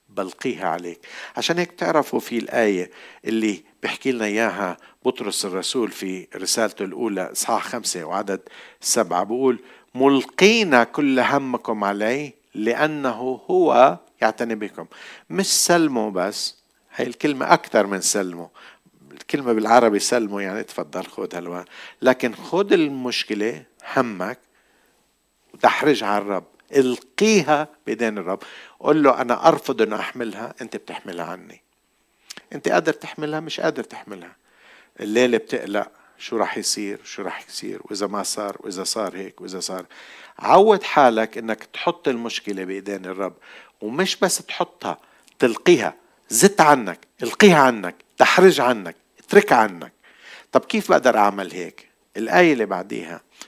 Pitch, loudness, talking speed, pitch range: 120 Hz, -20 LUFS, 125 wpm, 100-150 Hz